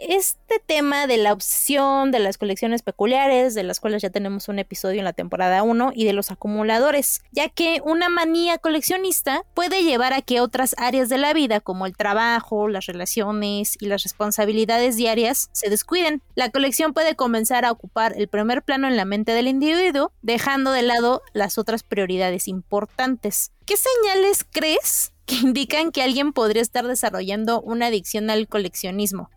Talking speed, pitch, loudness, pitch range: 170 wpm, 235 Hz, -21 LUFS, 210-280 Hz